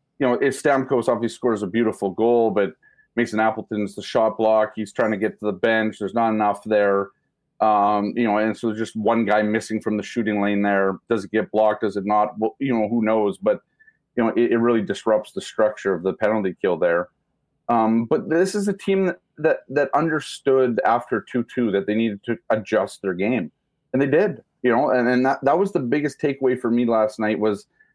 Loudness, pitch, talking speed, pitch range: -21 LUFS, 110 Hz, 225 wpm, 105-125 Hz